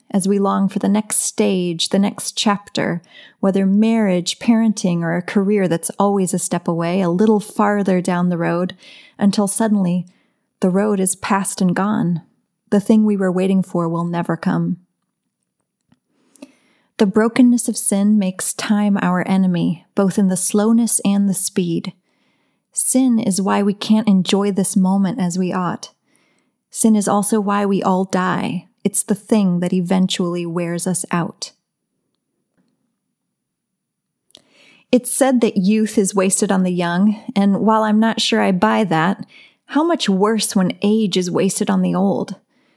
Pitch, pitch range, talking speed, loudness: 200 Hz, 185-215 Hz, 155 wpm, -17 LUFS